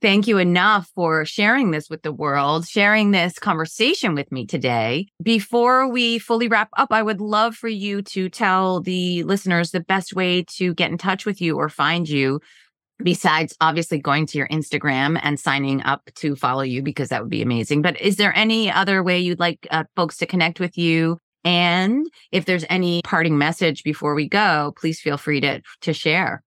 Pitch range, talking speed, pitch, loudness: 155-195 Hz, 195 wpm, 175 Hz, -20 LUFS